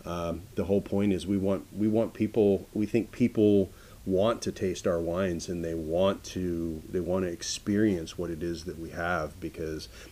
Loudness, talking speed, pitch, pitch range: -29 LUFS, 195 wpm, 95 Hz, 85-105 Hz